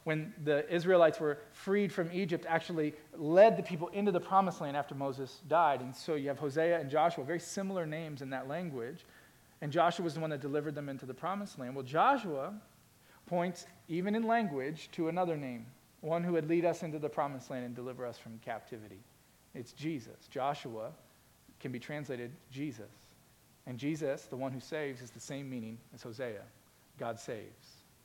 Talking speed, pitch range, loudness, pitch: 185 wpm, 135-170 Hz, -35 LUFS, 150 Hz